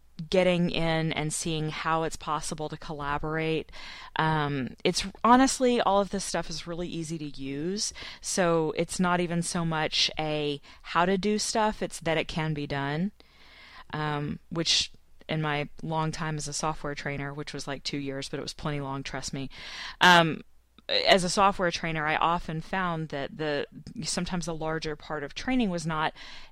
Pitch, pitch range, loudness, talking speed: 160 Hz, 150-175 Hz, -28 LUFS, 175 wpm